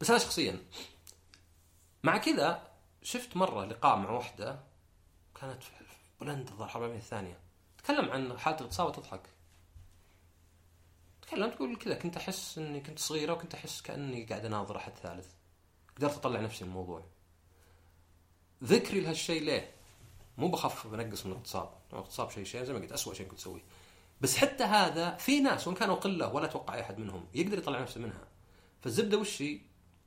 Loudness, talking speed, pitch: -34 LUFS, 150 wpm, 105 Hz